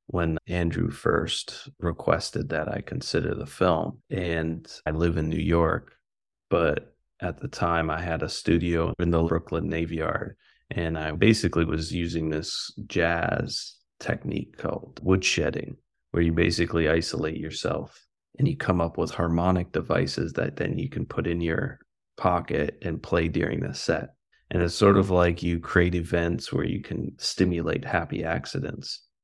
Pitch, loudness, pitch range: 85 Hz, -27 LUFS, 80-85 Hz